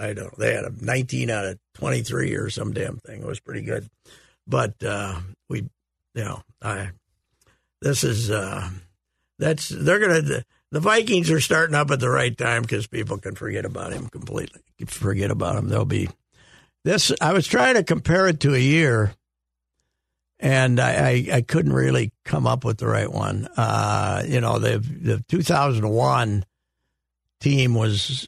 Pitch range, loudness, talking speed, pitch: 95-130 Hz, -22 LUFS, 175 wpm, 115 Hz